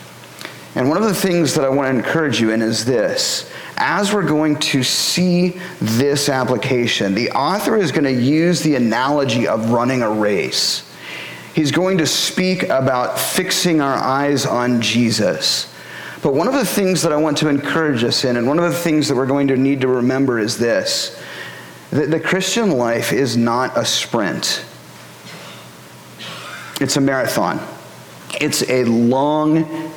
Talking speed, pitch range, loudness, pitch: 165 wpm, 120-170 Hz, -17 LUFS, 140 Hz